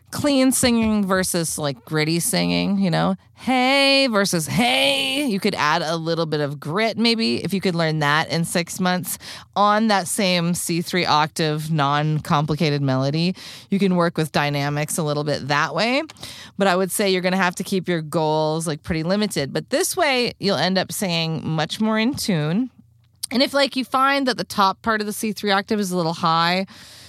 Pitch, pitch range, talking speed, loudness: 180 Hz, 155-210 Hz, 195 wpm, -20 LUFS